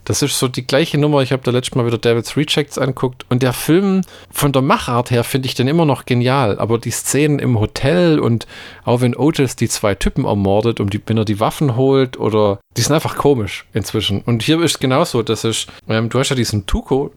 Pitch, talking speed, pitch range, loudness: 125 Hz, 240 wpm, 115-140 Hz, -16 LUFS